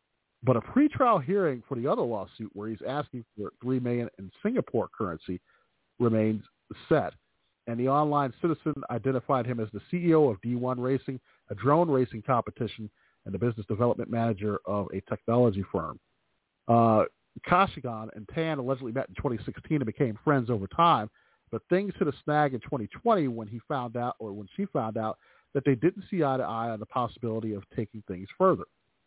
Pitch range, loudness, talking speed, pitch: 110-140 Hz, -29 LUFS, 180 wpm, 120 Hz